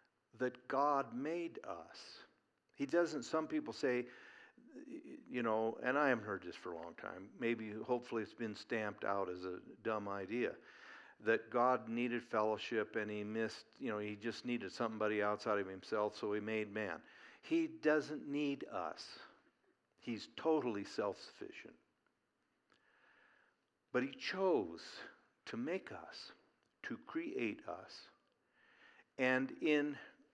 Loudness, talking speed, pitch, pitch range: -40 LUFS, 135 wpm, 120 Hz, 105-150 Hz